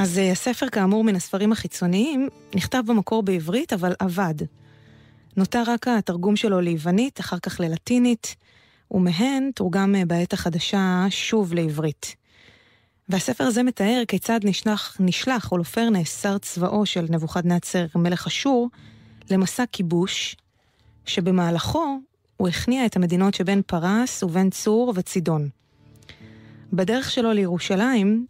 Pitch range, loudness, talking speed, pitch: 170-220 Hz, -22 LUFS, 115 wpm, 190 Hz